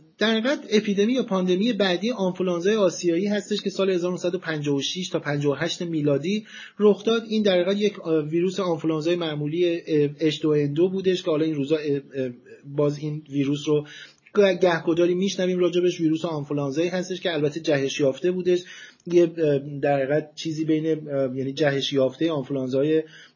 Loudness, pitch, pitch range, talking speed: -24 LUFS, 165 Hz, 150-185 Hz, 140 wpm